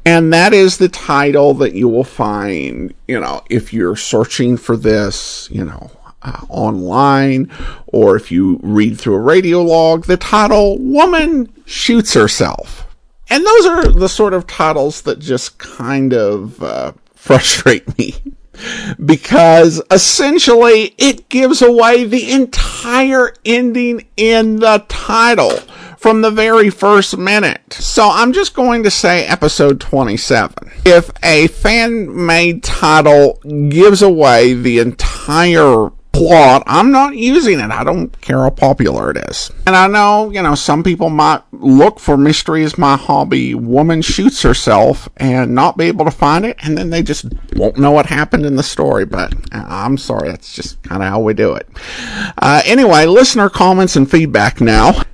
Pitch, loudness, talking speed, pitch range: 170 Hz, -10 LUFS, 160 wpm, 140-225 Hz